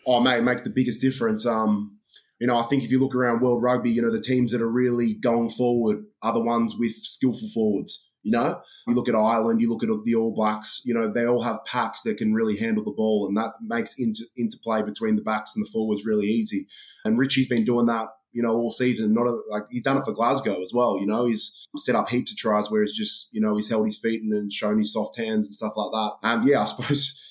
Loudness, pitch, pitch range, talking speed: -24 LUFS, 115 Hz, 110-125 Hz, 265 wpm